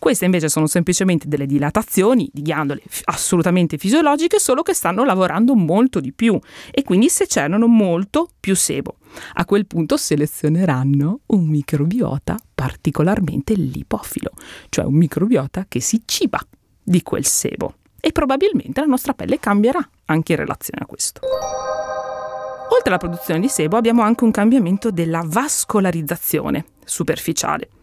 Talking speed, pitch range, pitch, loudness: 140 wpm, 155-230 Hz, 185 Hz, -18 LUFS